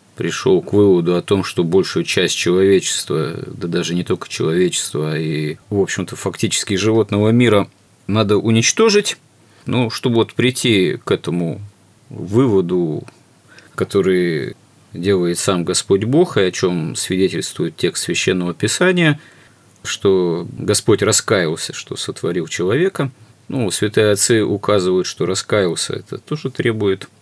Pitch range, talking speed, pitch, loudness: 95-125 Hz, 125 wpm, 105 Hz, -17 LUFS